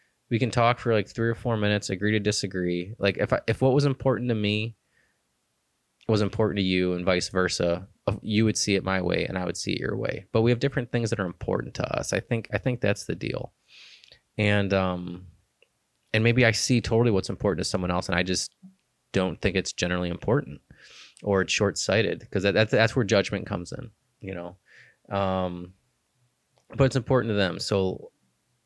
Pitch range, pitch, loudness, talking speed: 95-115 Hz, 105 Hz, -26 LUFS, 205 wpm